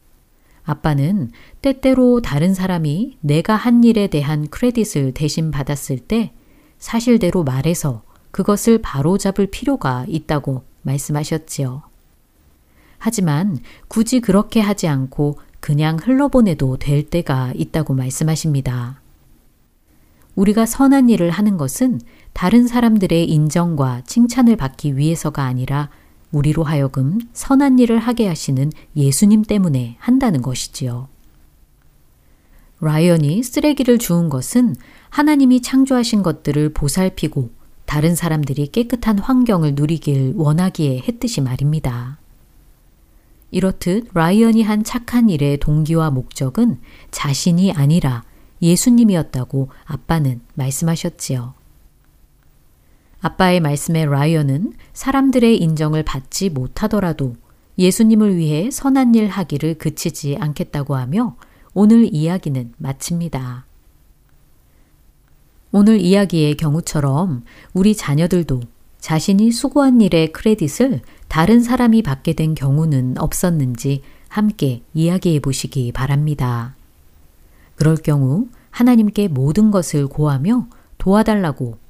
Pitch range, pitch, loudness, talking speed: 135-210 Hz, 160 Hz, -17 LUFS, 270 characters per minute